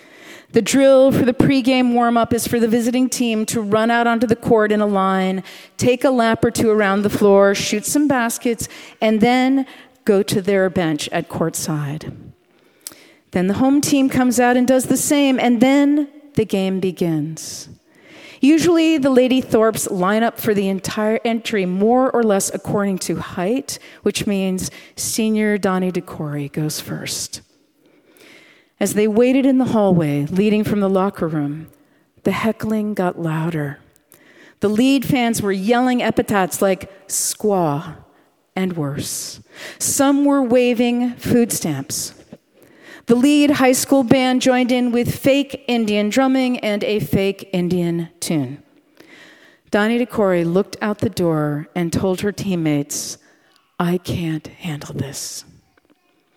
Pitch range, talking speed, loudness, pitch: 185-255 Hz, 145 wpm, -18 LUFS, 220 Hz